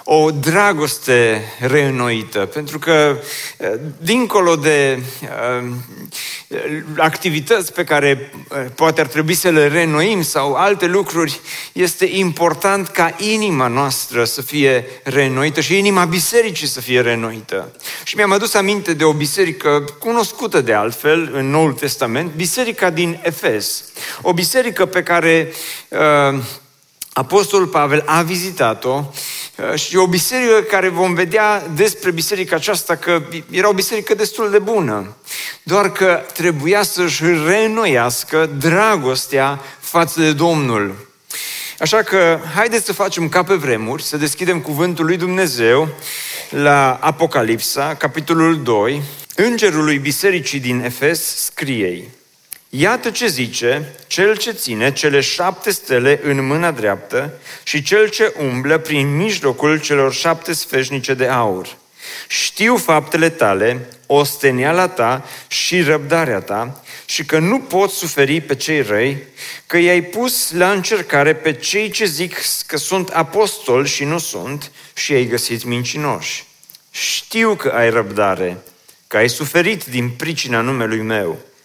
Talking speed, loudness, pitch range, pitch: 130 wpm, -16 LUFS, 140-185 Hz, 160 Hz